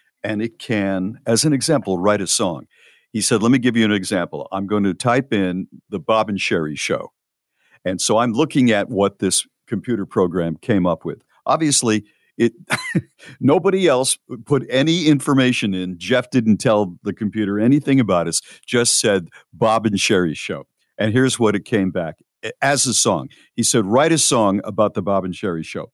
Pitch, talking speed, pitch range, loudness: 110 Hz, 185 wpm, 100-125 Hz, -18 LUFS